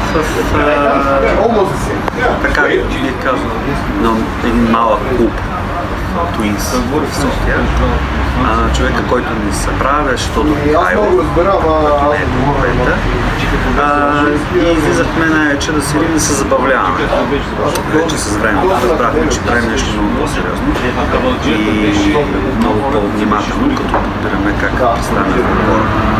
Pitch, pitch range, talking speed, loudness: 115 Hz, 105-145 Hz, 120 wpm, -13 LUFS